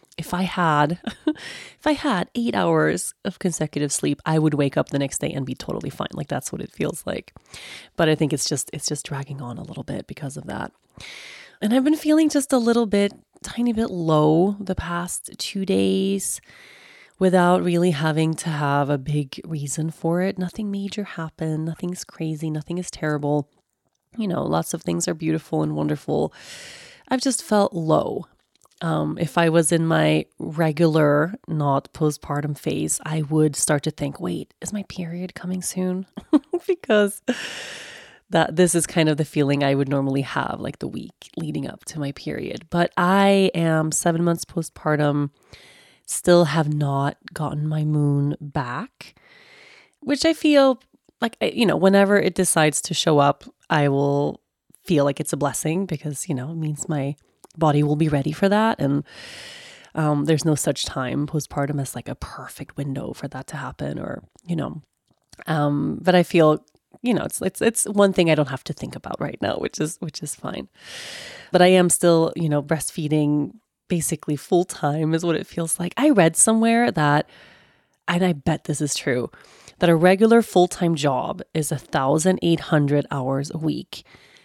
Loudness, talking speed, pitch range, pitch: -22 LUFS, 180 wpm, 145-185 Hz, 160 Hz